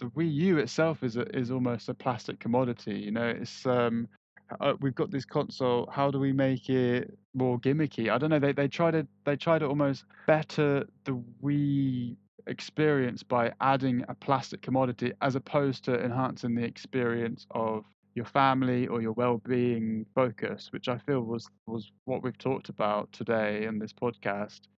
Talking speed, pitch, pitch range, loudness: 175 wpm, 125 Hz, 115-140 Hz, -30 LUFS